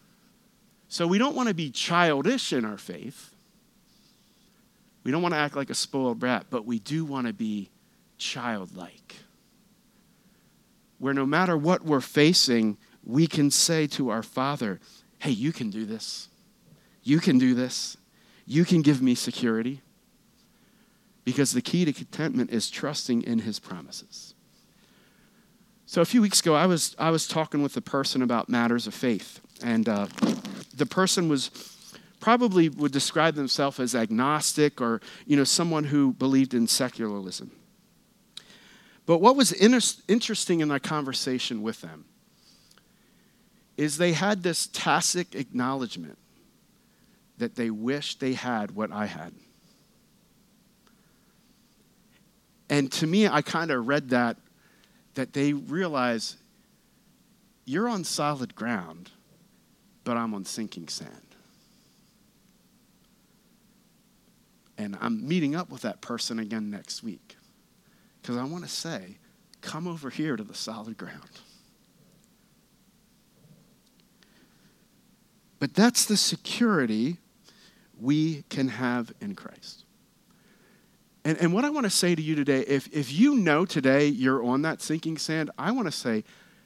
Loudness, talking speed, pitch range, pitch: -26 LUFS, 135 wpm, 130-210 Hz, 160 Hz